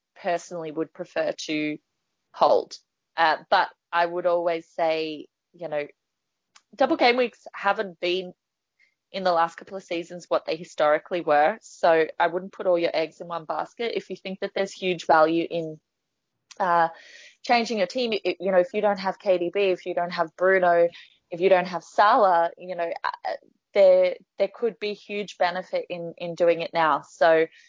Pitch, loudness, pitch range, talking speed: 180 Hz, -24 LUFS, 170-195 Hz, 180 wpm